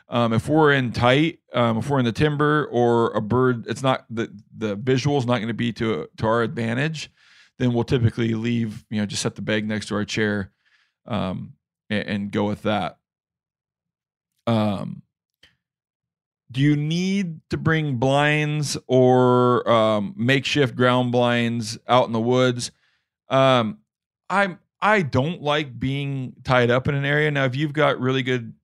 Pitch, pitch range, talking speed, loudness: 125 Hz, 115-145 Hz, 170 wpm, -21 LUFS